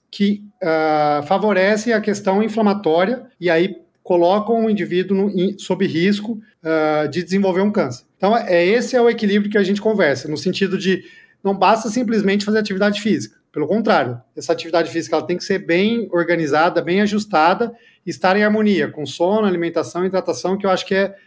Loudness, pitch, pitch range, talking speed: -18 LUFS, 190 Hz, 170-210 Hz, 190 wpm